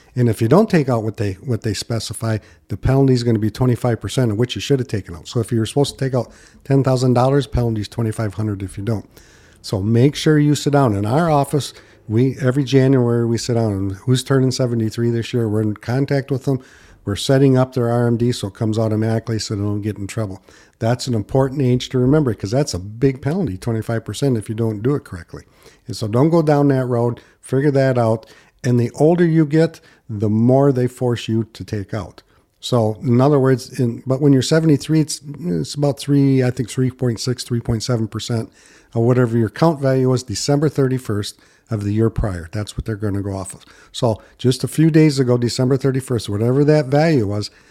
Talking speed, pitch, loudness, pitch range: 225 wpm, 120 Hz, -18 LUFS, 110-135 Hz